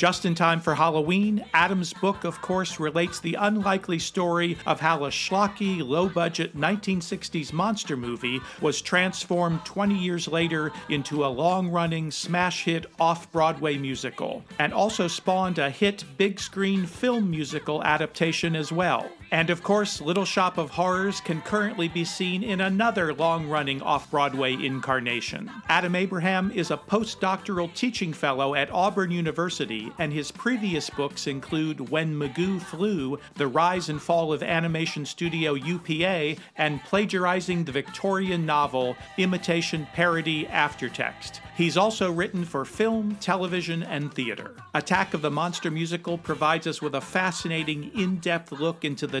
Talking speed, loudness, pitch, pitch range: 150 wpm, -26 LUFS, 170 Hz, 155-185 Hz